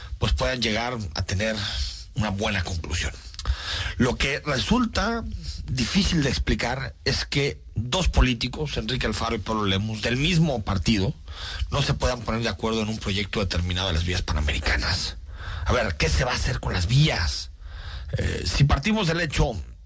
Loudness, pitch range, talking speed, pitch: -25 LUFS, 85-120 Hz, 165 wpm, 100 Hz